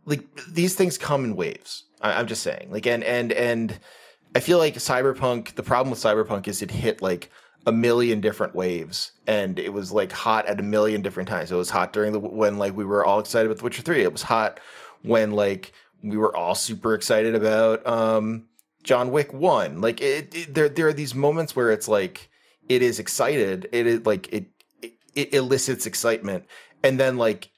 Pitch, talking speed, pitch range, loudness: 115 Hz, 210 wpm, 105-130 Hz, -23 LUFS